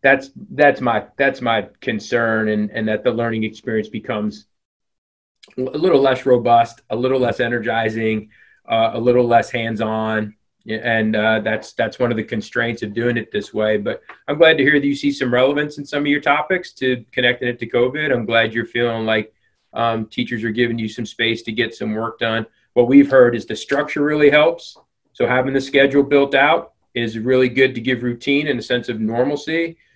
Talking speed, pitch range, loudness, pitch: 200 wpm, 110-135 Hz, -18 LUFS, 120 Hz